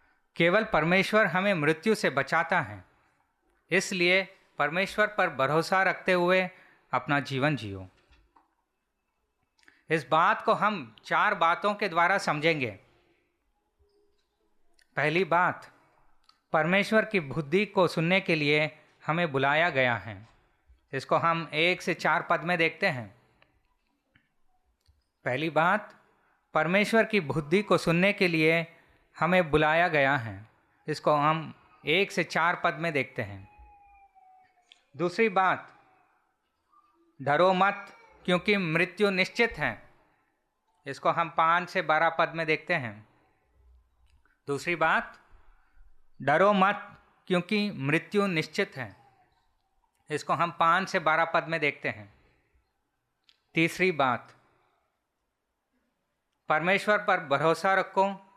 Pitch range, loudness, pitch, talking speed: 150-195 Hz, -26 LUFS, 170 Hz, 115 wpm